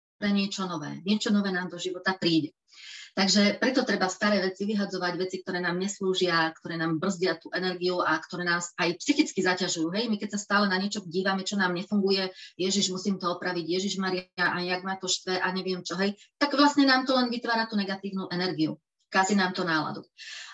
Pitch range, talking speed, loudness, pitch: 180-200 Hz, 200 wpm, -27 LUFS, 185 Hz